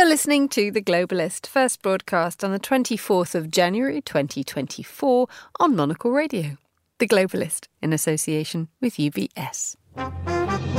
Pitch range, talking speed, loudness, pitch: 155-245 Hz, 120 wpm, -23 LUFS, 180 Hz